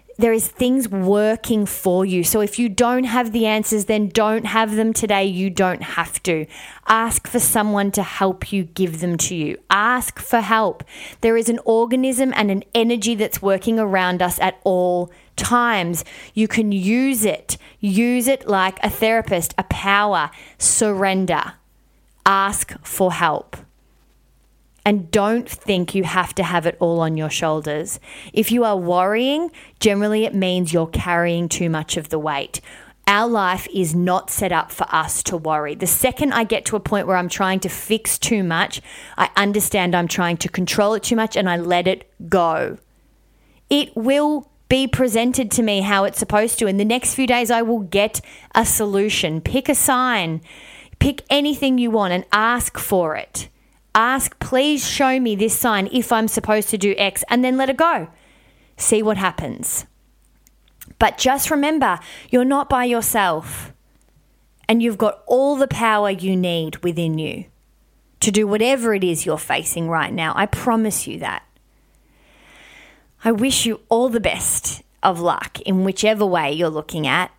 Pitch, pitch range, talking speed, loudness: 210 Hz, 180-235 Hz, 175 wpm, -19 LUFS